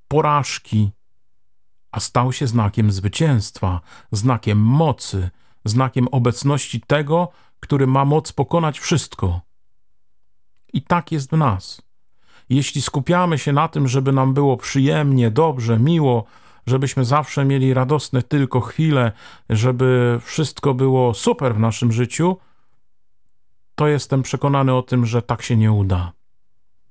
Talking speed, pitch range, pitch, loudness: 125 wpm, 115-145 Hz, 130 Hz, -18 LUFS